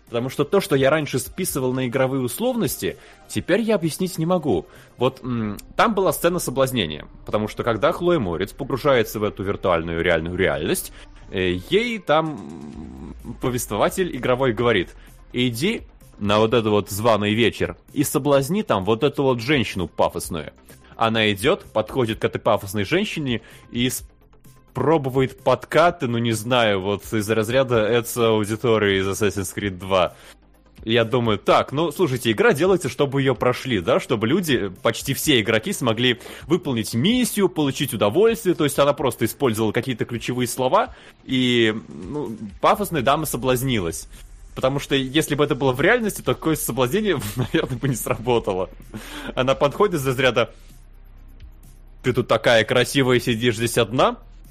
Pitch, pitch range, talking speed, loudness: 125 Hz, 110-145 Hz, 150 wpm, -21 LUFS